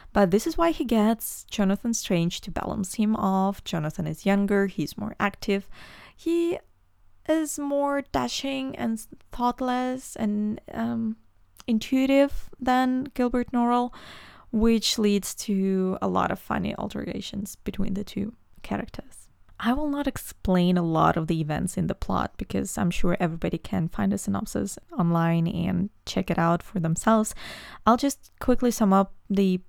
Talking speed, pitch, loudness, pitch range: 150 wpm, 210 Hz, -26 LUFS, 190-245 Hz